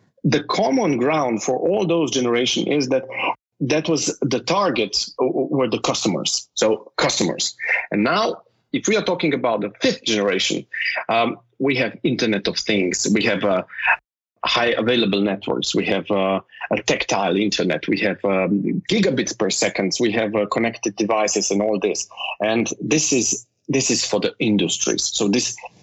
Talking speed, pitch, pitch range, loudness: 165 wpm, 110 Hz, 100-135 Hz, -20 LUFS